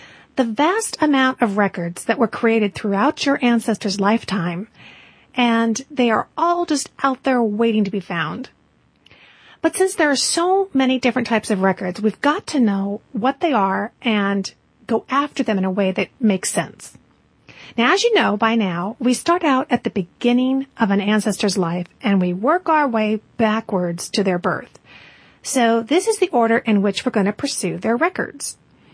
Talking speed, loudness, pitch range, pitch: 180 wpm, -19 LUFS, 205-270 Hz, 230 Hz